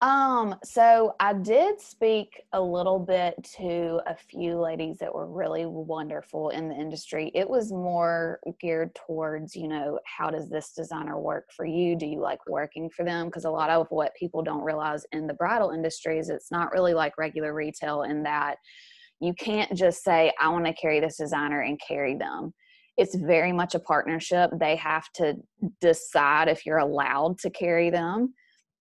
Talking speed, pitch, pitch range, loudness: 185 wpm, 165 Hz, 155-185 Hz, -27 LUFS